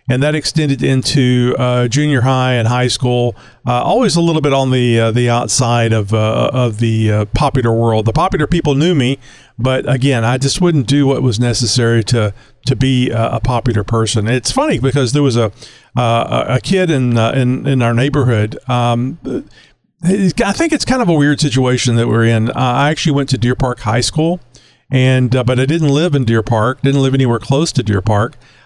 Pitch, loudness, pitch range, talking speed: 130 Hz, -14 LUFS, 120-140 Hz, 205 wpm